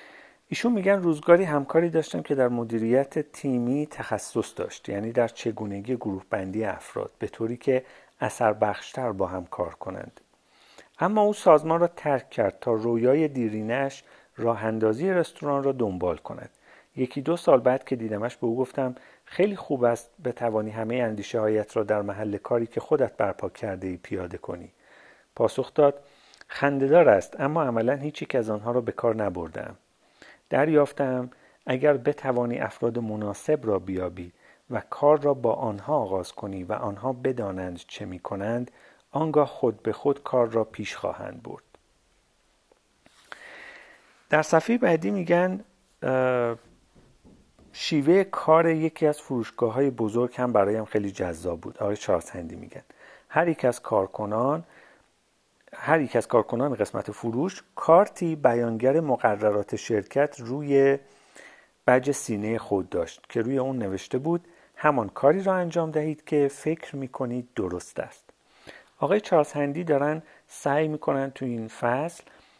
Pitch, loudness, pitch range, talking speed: 130 Hz, -26 LUFS, 115-150 Hz, 145 wpm